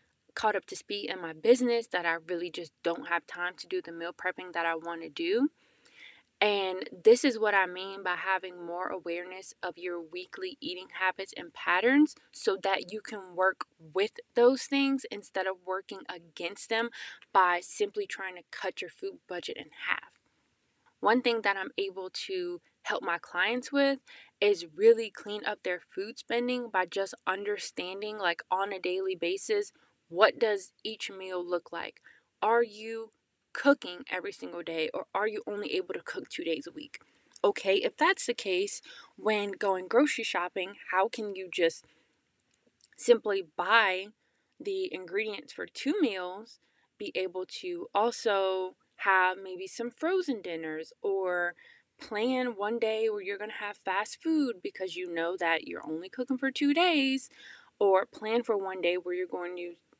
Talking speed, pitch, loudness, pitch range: 170 wpm, 205 Hz, -31 LUFS, 185-275 Hz